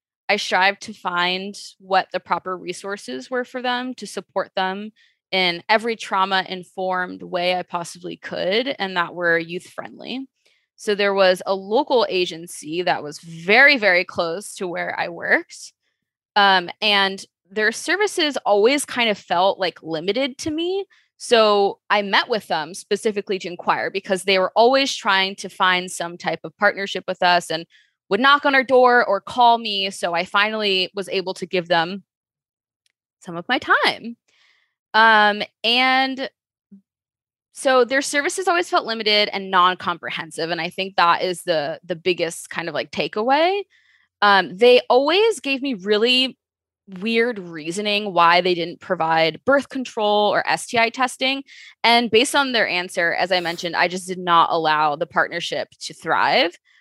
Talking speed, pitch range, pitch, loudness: 160 wpm, 180-240 Hz, 200 Hz, -19 LUFS